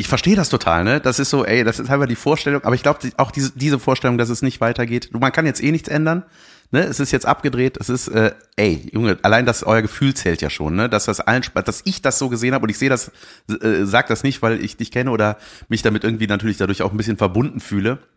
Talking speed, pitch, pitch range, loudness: 270 wpm, 120 Hz, 110-135 Hz, -18 LUFS